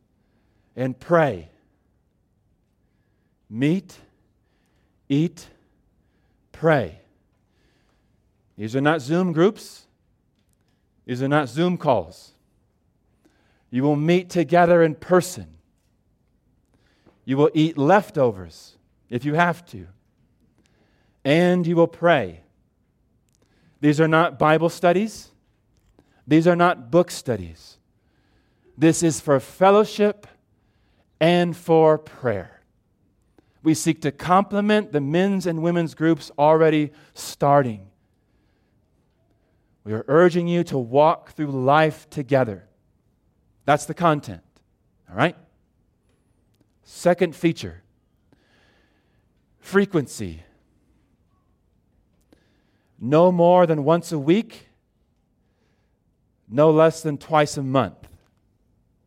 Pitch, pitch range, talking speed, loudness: 145 Hz, 105-165 Hz, 90 wpm, -20 LUFS